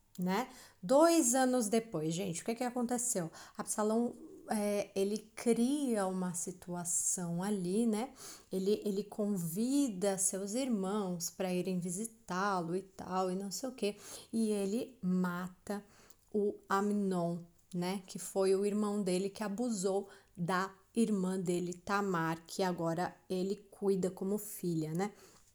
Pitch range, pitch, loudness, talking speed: 185-215 Hz, 195 Hz, -35 LUFS, 130 wpm